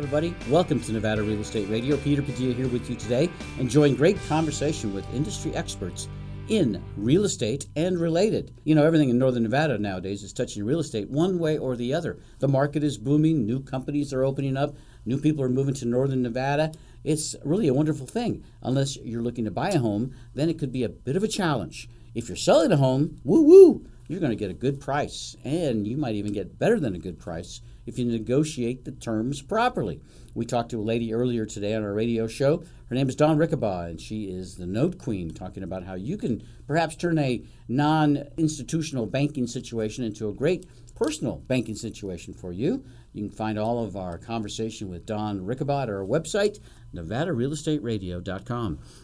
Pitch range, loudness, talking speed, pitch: 110-150 Hz, -25 LUFS, 195 wpm, 125 Hz